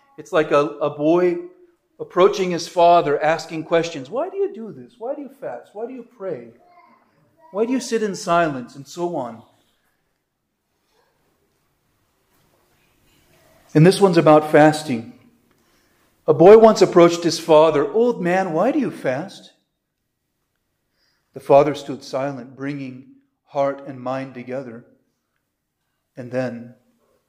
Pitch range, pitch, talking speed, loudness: 140-215 Hz, 165 Hz, 130 wpm, -18 LUFS